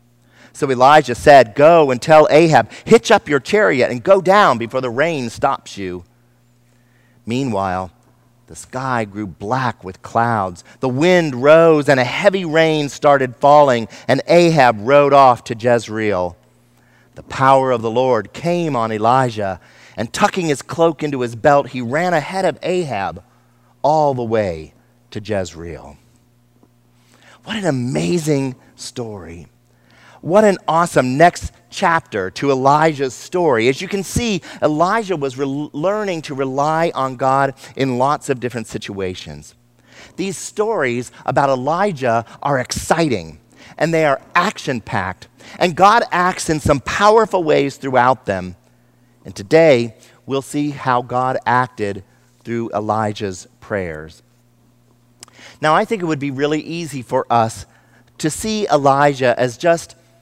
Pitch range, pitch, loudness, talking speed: 115-155 Hz, 130 Hz, -16 LUFS, 140 wpm